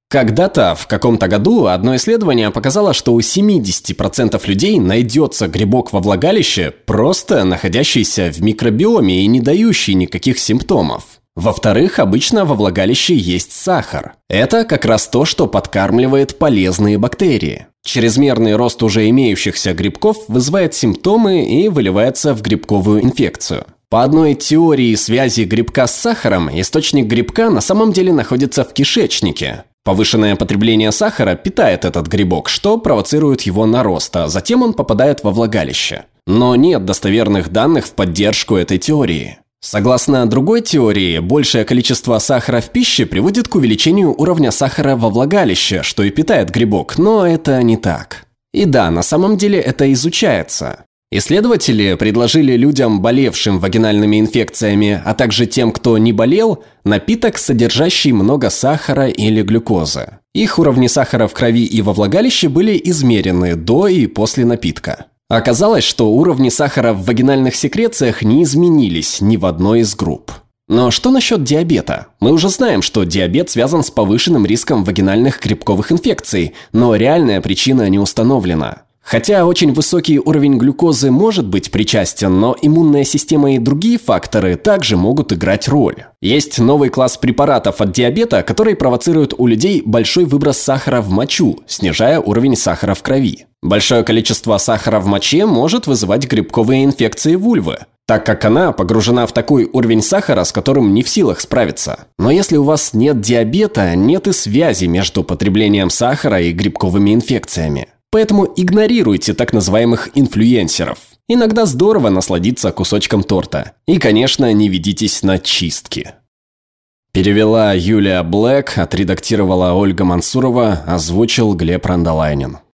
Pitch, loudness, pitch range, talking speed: 115 Hz, -12 LUFS, 105-145 Hz, 140 wpm